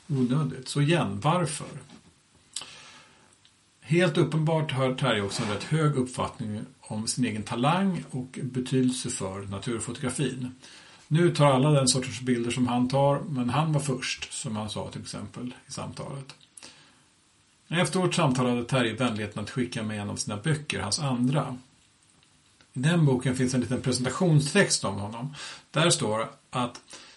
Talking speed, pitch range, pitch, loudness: 150 wpm, 120-145 Hz, 130 Hz, -27 LUFS